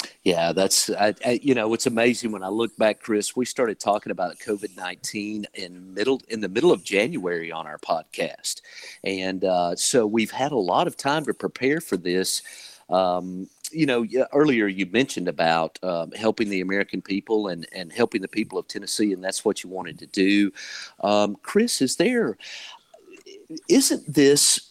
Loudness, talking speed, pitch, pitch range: -23 LUFS, 175 wpm, 105 Hz, 95-130 Hz